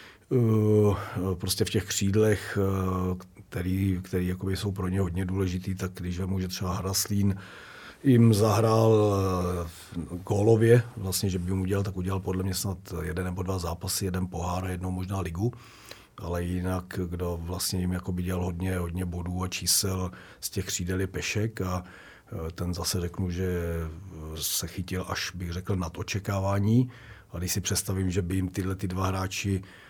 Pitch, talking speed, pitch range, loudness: 95 Hz, 170 wpm, 90-100 Hz, -28 LUFS